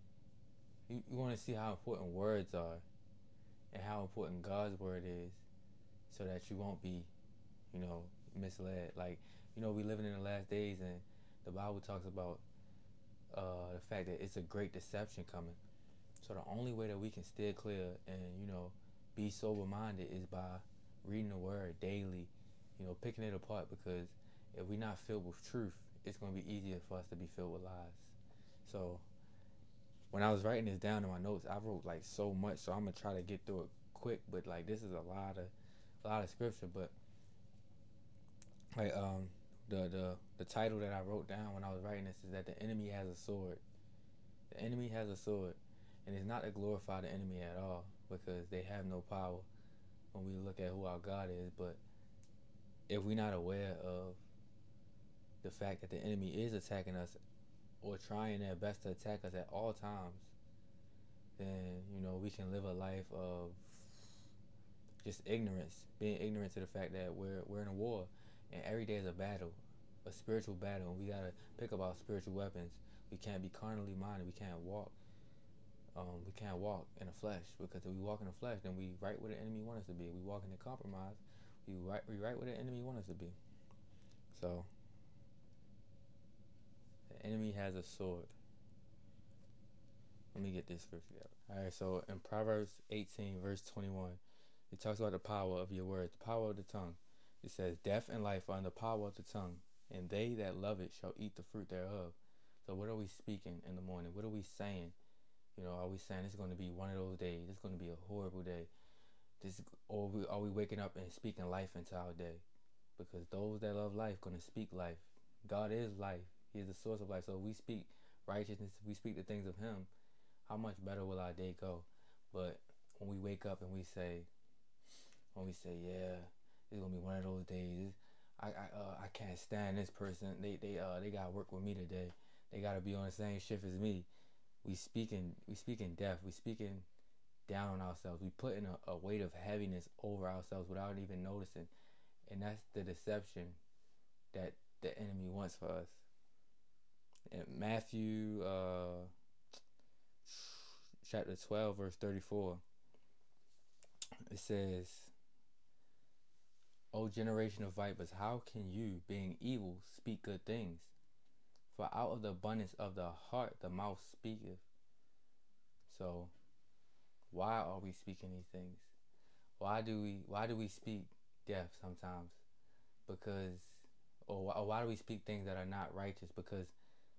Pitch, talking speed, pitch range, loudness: 100 Hz, 190 wpm, 90-105 Hz, -47 LUFS